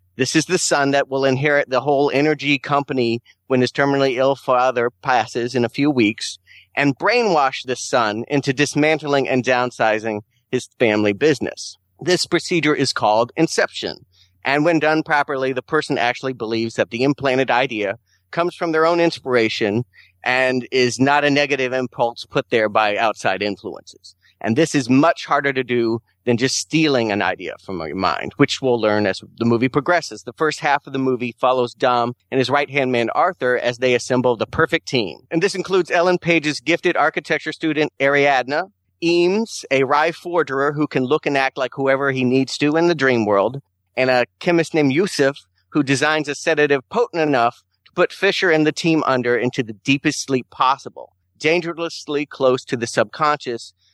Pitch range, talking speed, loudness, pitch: 120-150 Hz, 180 wpm, -19 LUFS, 135 Hz